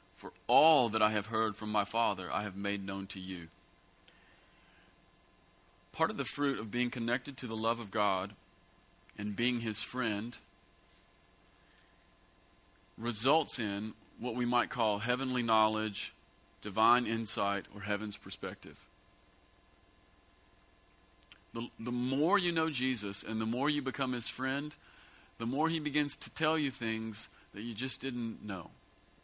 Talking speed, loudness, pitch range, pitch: 145 wpm, -34 LUFS, 95-125 Hz, 110 Hz